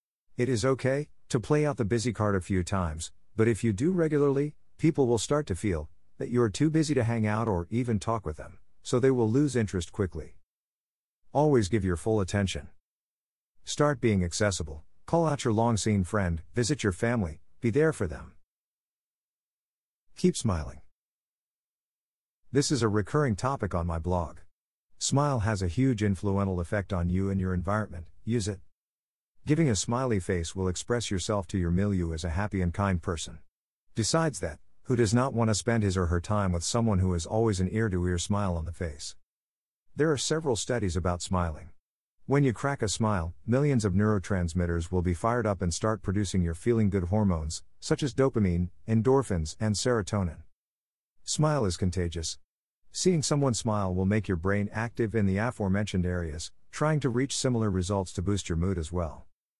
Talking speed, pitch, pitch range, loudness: 180 wpm, 105 Hz, 90-120 Hz, -28 LUFS